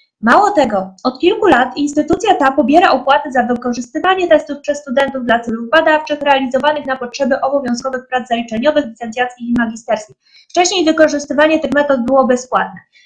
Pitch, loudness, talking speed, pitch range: 275 Hz, -14 LUFS, 145 wpm, 245-305 Hz